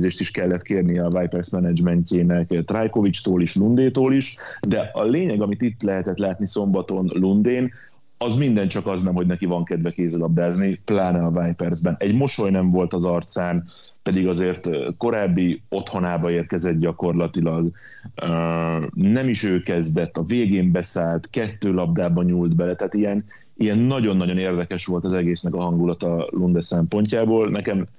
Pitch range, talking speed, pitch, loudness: 85-100 Hz, 145 wpm, 90 Hz, -21 LUFS